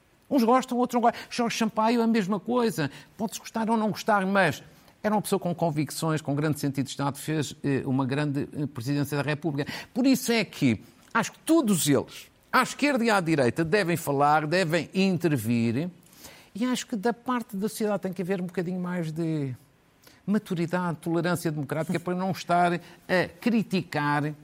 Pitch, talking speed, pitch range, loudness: 175 Hz, 175 wpm, 150-215 Hz, -27 LUFS